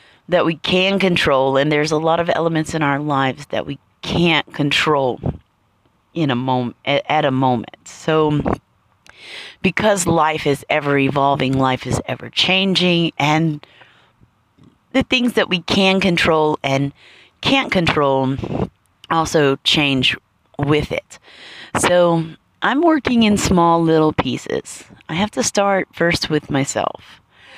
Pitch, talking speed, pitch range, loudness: 155 Hz, 135 wpm, 135-175 Hz, -17 LUFS